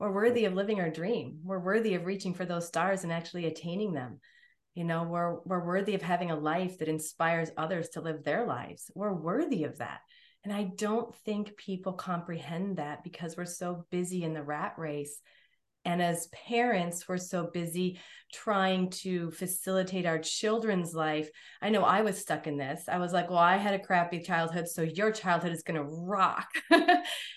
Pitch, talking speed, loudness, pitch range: 180 Hz, 190 wpm, -32 LUFS, 165-195 Hz